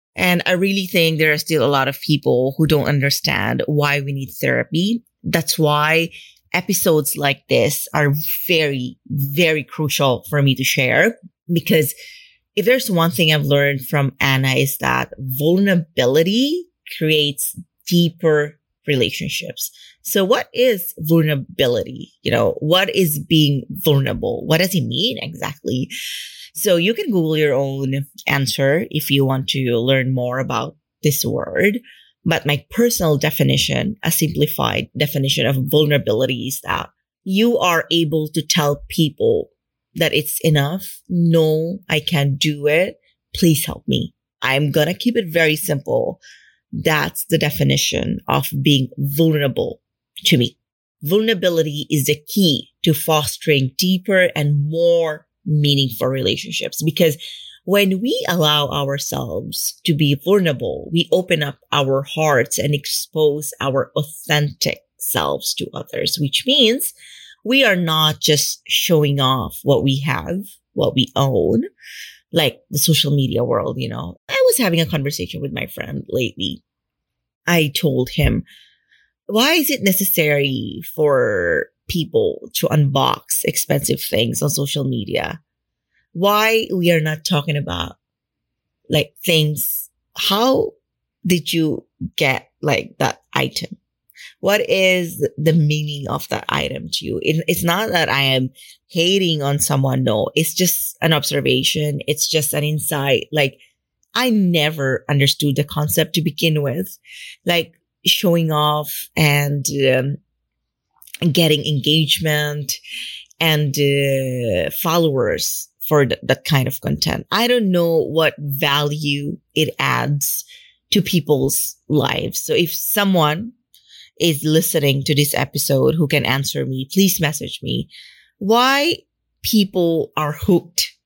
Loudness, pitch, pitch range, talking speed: -18 LUFS, 155 Hz, 140-175 Hz, 135 wpm